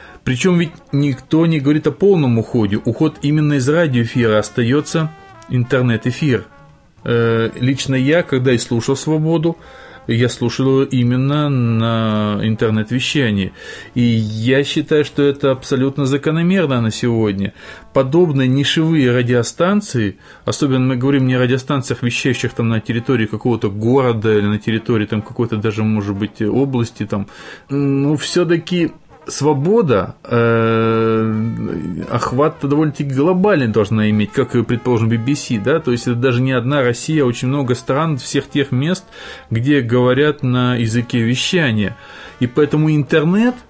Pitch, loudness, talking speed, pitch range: 130 Hz, -16 LUFS, 130 wpm, 115-145 Hz